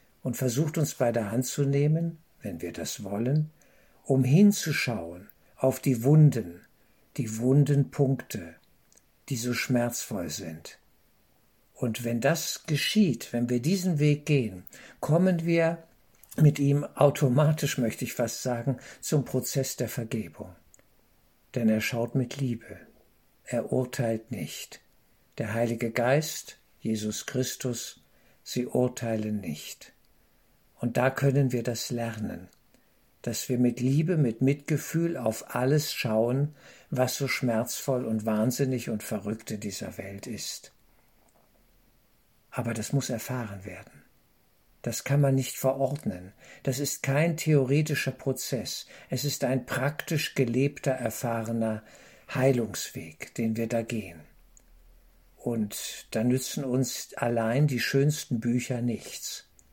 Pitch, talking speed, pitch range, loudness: 125 Hz, 125 wpm, 115-140 Hz, -28 LUFS